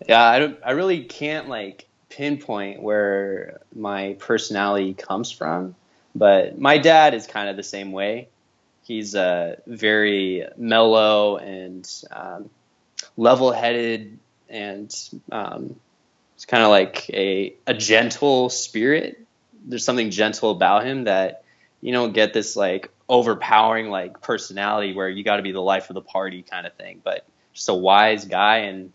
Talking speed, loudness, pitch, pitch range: 155 wpm, -20 LUFS, 105 Hz, 95-115 Hz